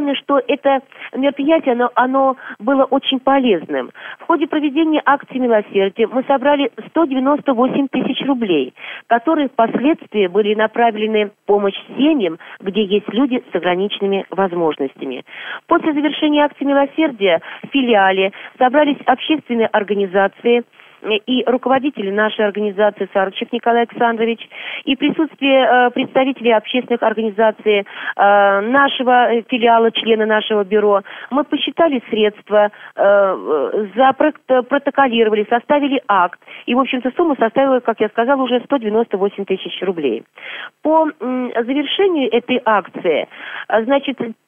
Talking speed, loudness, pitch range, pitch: 115 wpm, -16 LUFS, 215-280 Hz, 245 Hz